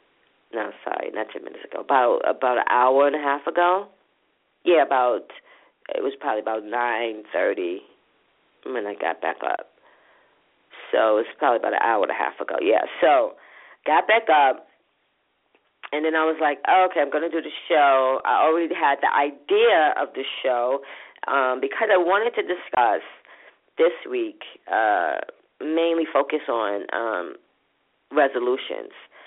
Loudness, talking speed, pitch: -22 LUFS, 160 wpm, 165 Hz